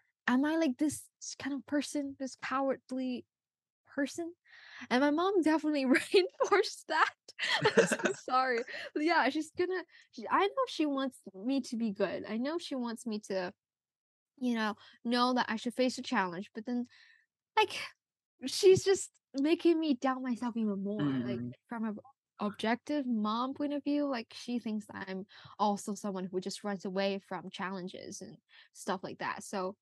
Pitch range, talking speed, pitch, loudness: 215-300 Hz, 165 wpm, 255 Hz, -33 LUFS